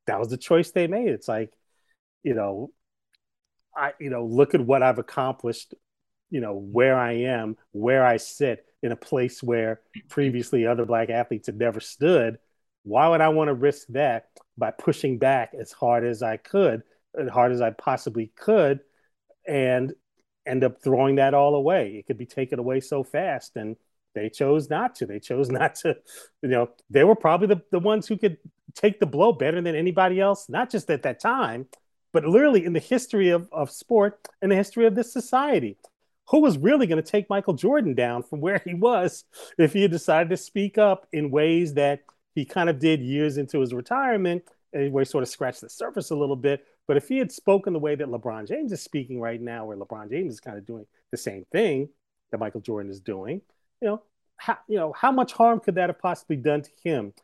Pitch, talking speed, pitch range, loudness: 150 Hz, 210 wpm, 125-195 Hz, -24 LUFS